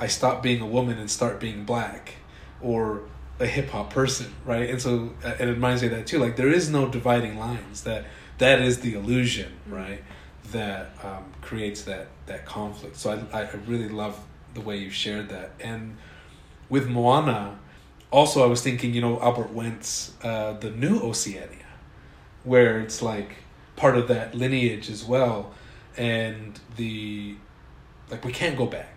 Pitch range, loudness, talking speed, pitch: 105-125 Hz, -25 LUFS, 170 wpm, 115 Hz